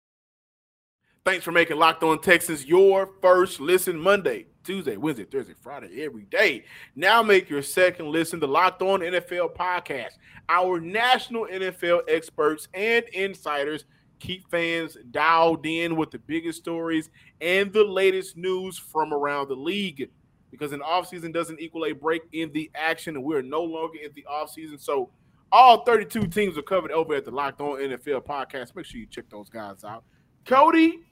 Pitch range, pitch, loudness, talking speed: 155-190 Hz, 170 Hz, -23 LUFS, 170 wpm